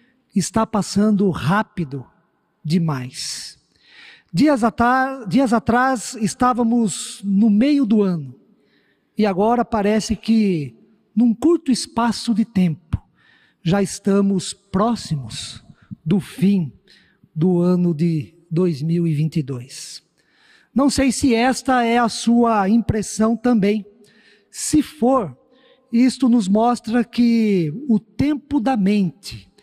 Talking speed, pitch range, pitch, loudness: 100 wpm, 175-240 Hz, 215 Hz, -19 LUFS